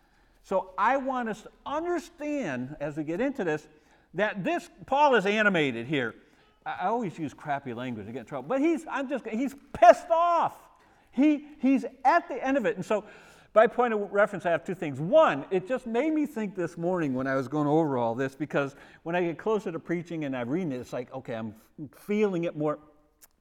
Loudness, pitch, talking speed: -28 LUFS, 185 Hz, 215 wpm